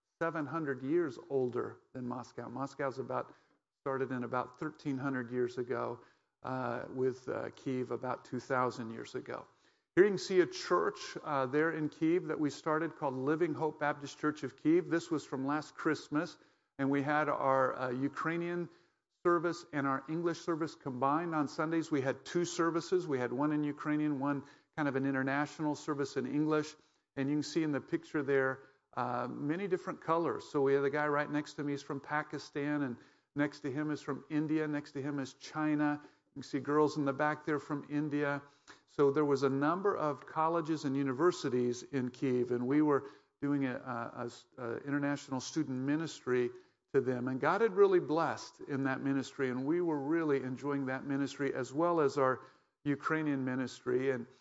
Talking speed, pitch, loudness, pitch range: 190 wpm, 145 Hz, -35 LUFS, 135-155 Hz